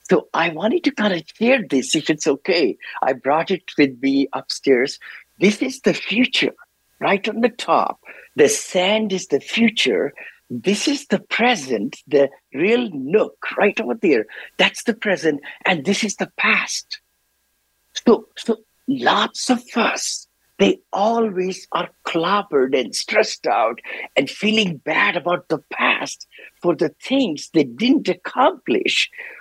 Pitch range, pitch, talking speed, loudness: 165-245 Hz, 205 Hz, 145 wpm, -19 LUFS